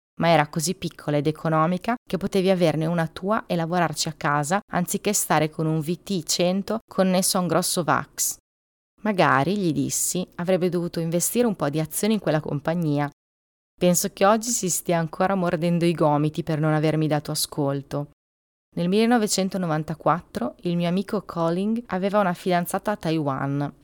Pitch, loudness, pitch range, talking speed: 170 Hz, -23 LUFS, 155-190 Hz, 160 wpm